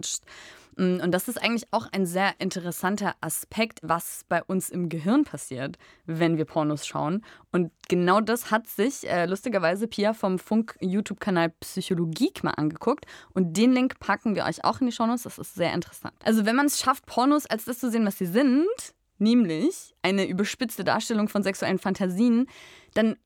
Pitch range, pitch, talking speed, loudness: 175-230 Hz, 200 Hz, 180 wpm, -26 LUFS